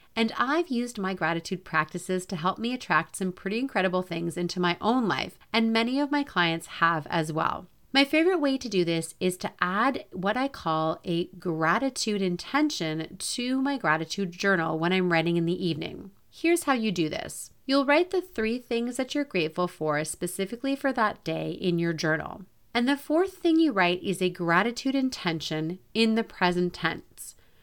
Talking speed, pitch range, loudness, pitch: 185 wpm, 170-255 Hz, -27 LUFS, 190 Hz